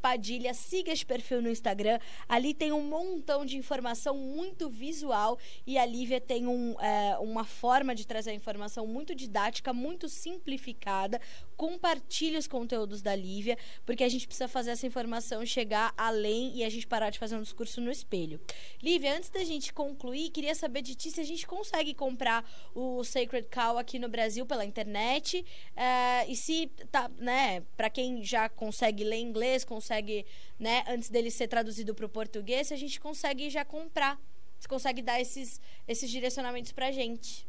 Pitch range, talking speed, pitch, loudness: 230-280 Hz, 180 wpm, 250 Hz, -33 LUFS